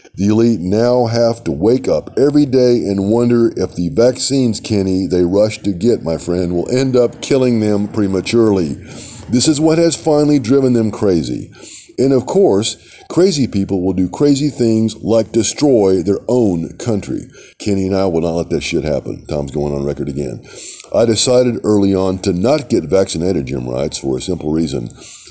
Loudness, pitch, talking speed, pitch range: -14 LUFS, 105 Hz, 185 wpm, 95-125 Hz